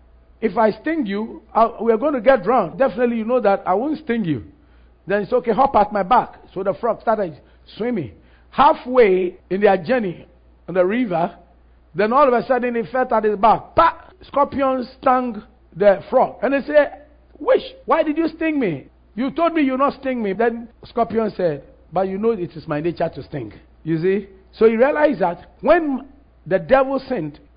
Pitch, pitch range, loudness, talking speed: 230 Hz, 190-270 Hz, -19 LUFS, 200 wpm